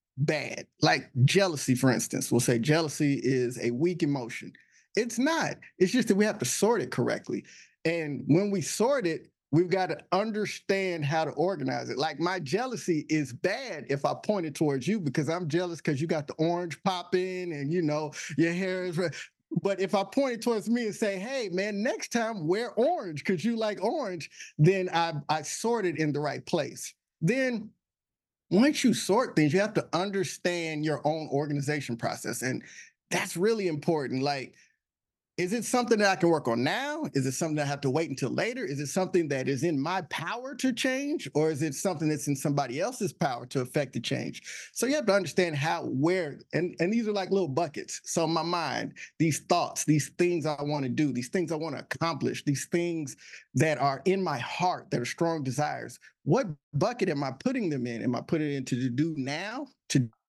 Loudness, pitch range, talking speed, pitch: -29 LUFS, 150-195 Hz, 210 wpm, 165 Hz